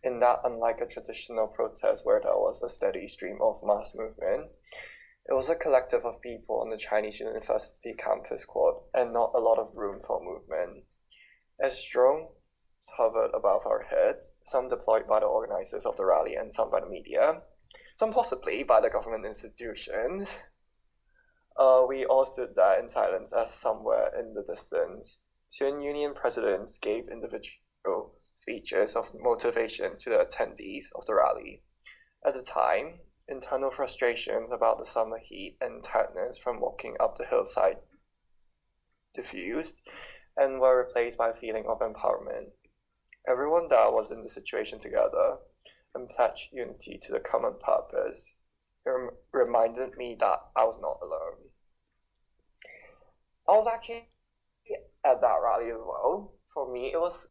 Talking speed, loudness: 150 wpm, -29 LUFS